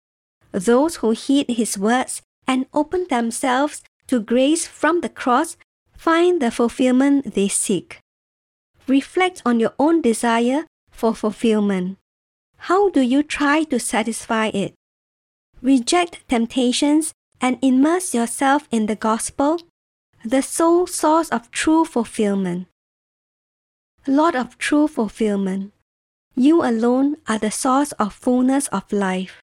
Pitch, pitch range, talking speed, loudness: 255 Hz, 220-295 Hz, 120 wpm, -19 LUFS